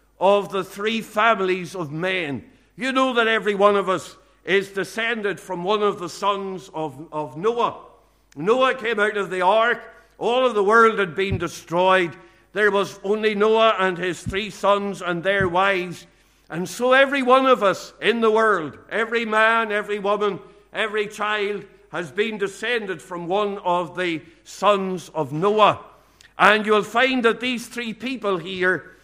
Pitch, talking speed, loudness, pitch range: 200 Hz, 165 wpm, -21 LUFS, 185-220 Hz